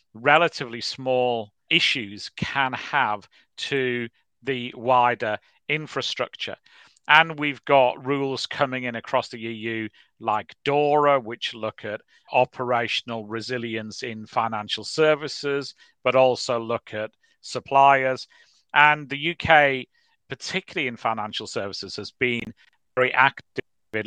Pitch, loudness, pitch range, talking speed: 125 Hz, -23 LUFS, 115-140 Hz, 110 wpm